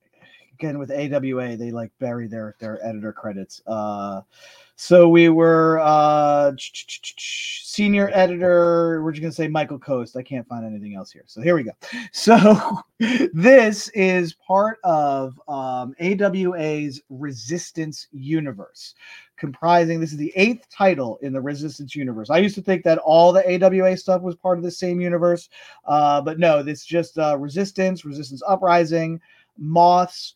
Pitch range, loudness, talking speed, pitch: 140-185 Hz, -19 LUFS, 155 wpm, 165 Hz